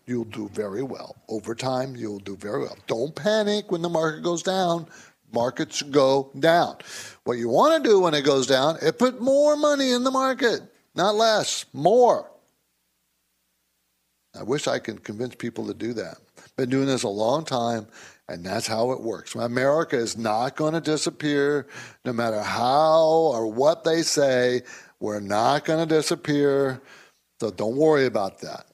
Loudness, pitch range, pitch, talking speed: -23 LUFS, 115-165 Hz, 135 Hz, 170 wpm